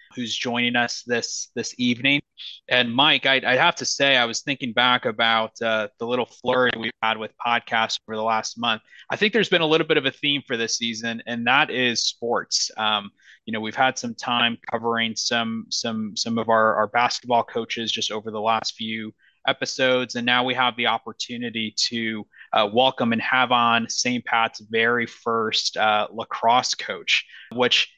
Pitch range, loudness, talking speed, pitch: 110-125 Hz, -22 LUFS, 190 wpm, 120 Hz